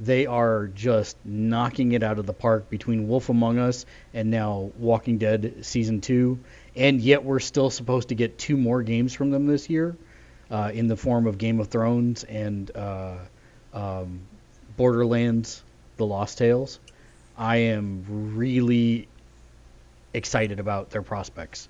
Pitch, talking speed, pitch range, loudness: 115 Hz, 150 wpm, 105-125 Hz, -24 LUFS